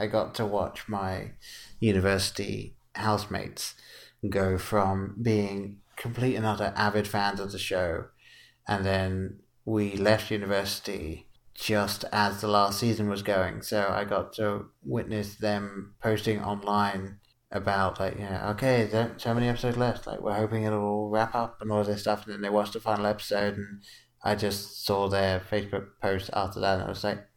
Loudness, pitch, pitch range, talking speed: -29 LUFS, 105 Hz, 100-110 Hz, 175 wpm